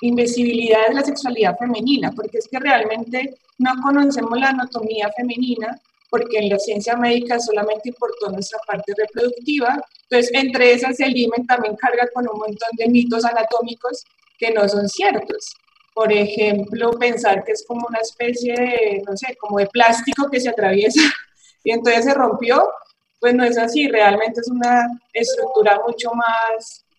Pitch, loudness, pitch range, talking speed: 235 Hz, -18 LUFS, 220-250 Hz, 160 wpm